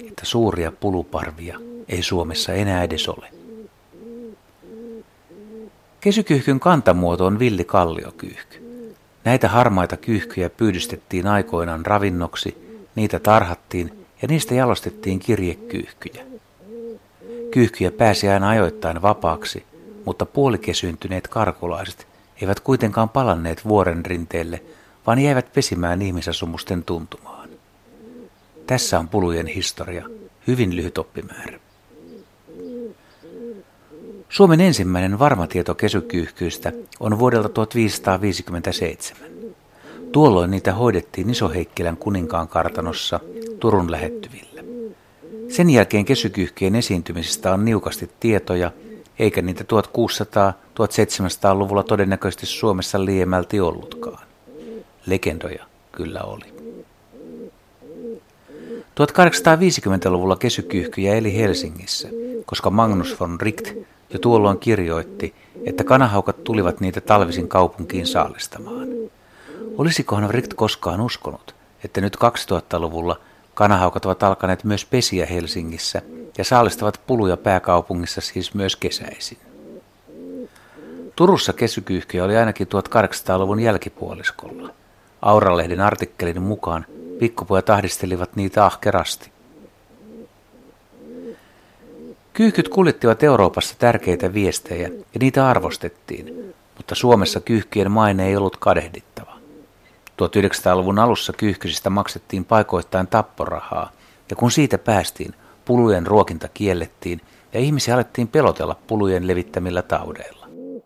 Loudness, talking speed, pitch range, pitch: -19 LUFS, 90 wpm, 90-120 Hz, 100 Hz